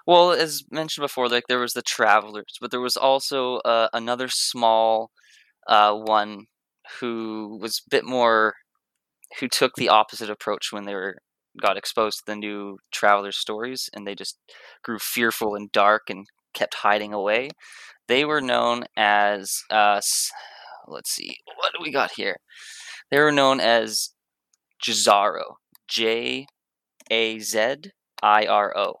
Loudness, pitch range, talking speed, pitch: -22 LUFS, 105-125 Hz, 150 wpm, 110 Hz